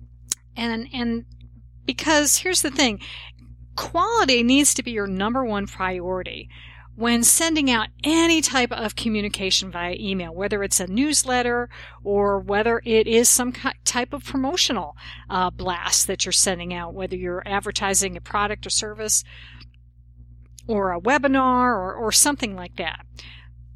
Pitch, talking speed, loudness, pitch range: 205 Hz, 140 wpm, -21 LUFS, 175-245 Hz